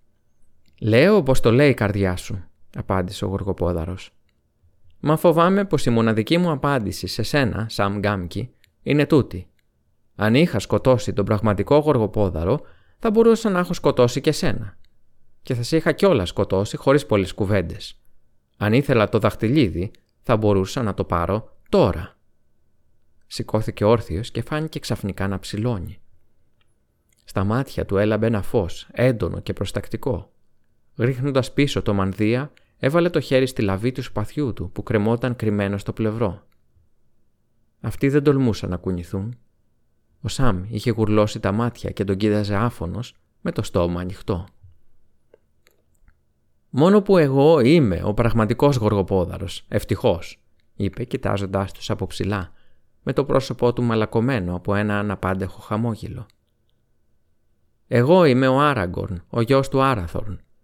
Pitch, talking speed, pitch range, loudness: 110 Hz, 135 wpm, 95-130 Hz, -21 LUFS